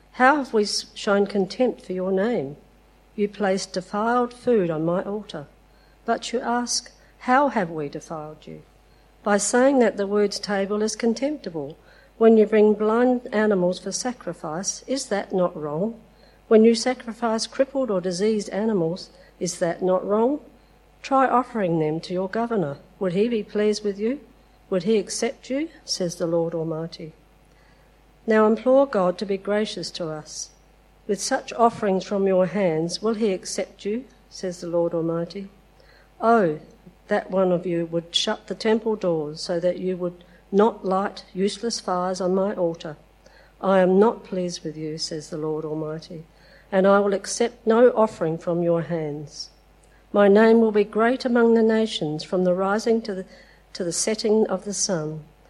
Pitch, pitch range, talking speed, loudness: 200 Hz, 175-225 Hz, 165 wpm, -23 LUFS